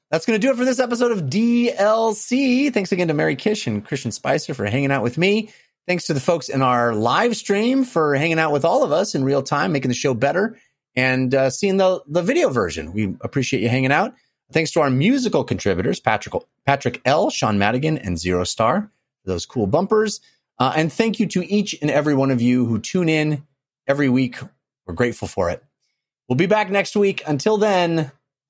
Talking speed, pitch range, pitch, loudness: 215 wpm, 130-205 Hz, 150 Hz, -20 LUFS